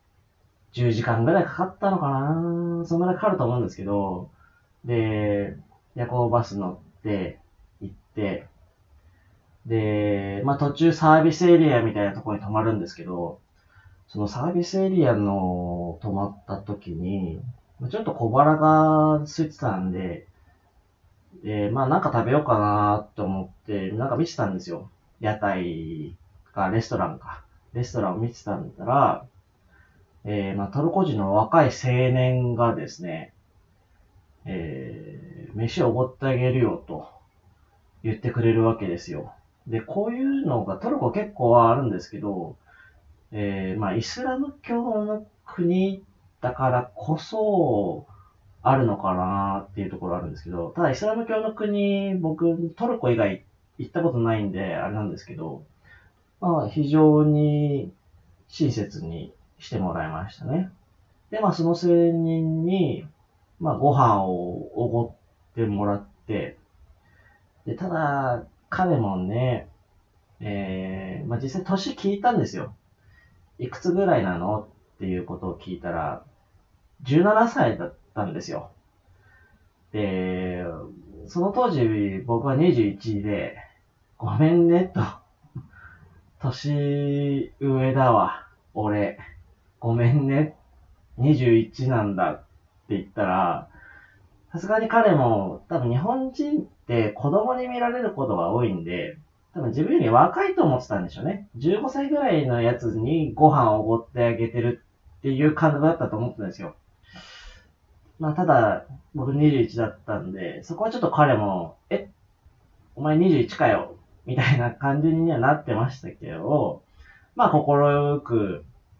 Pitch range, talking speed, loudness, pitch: 95-155 Hz, 260 characters per minute, -24 LUFS, 115 Hz